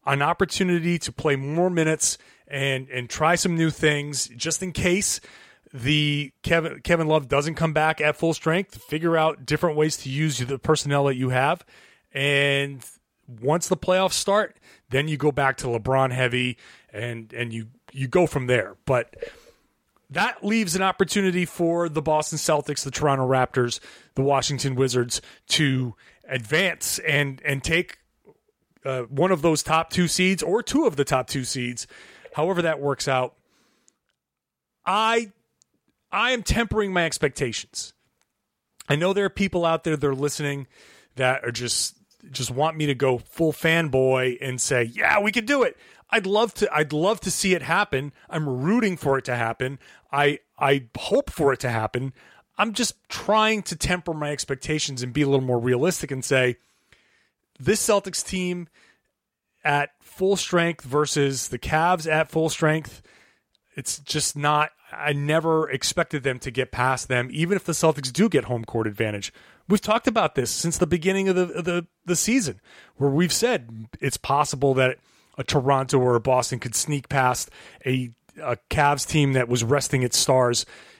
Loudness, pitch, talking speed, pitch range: -23 LUFS, 150 Hz, 170 wpm, 130-175 Hz